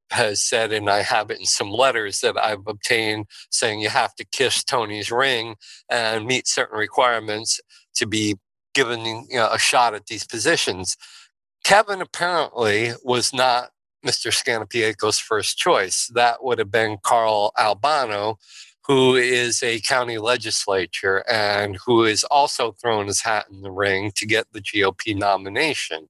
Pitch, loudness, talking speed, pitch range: 110 Hz, -20 LUFS, 155 wpm, 105-120 Hz